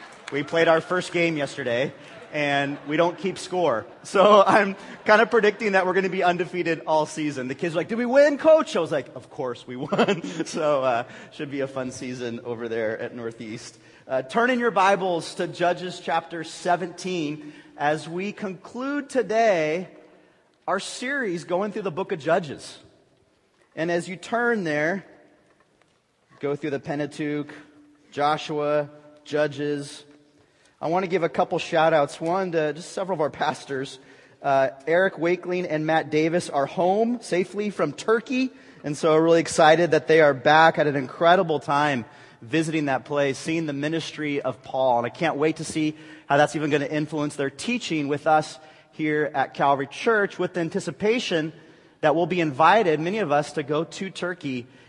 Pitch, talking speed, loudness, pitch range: 160 Hz, 180 wpm, -23 LUFS, 145-180 Hz